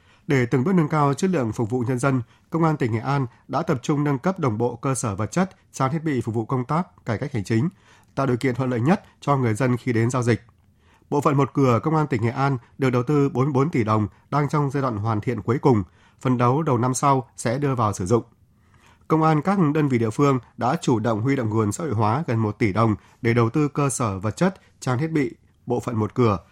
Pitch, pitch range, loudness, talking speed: 130 Hz, 115-145 Hz, -23 LUFS, 265 wpm